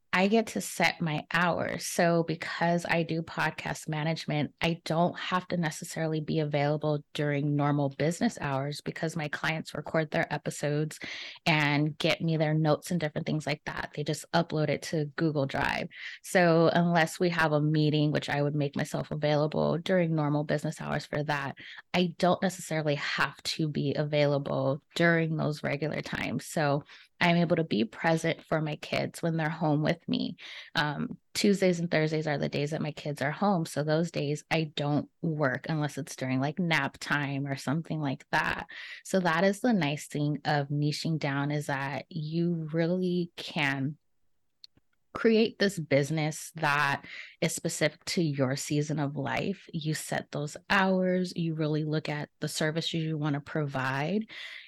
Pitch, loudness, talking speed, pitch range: 155 Hz, -29 LUFS, 170 wpm, 145-170 Hz